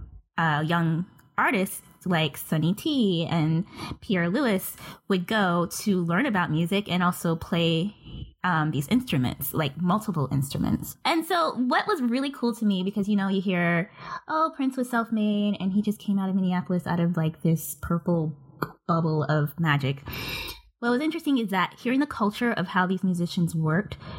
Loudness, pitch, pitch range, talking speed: -26 LUFS, 180 Hz, 165-210 Hz, 170 wpm